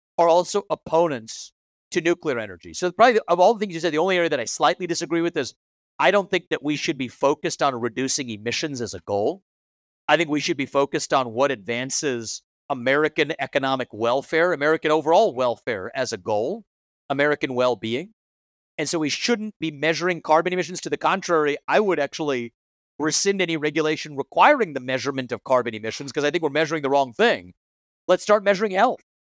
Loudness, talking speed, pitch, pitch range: -22 LUFS, 190 wpm, 150 Hz, 130-170 Hz